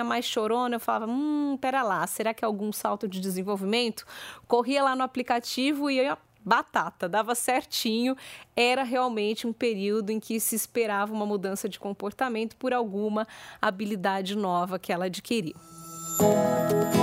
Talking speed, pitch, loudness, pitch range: 150 wpm, 220 Hz, -27 LUFS, 205-245 Hz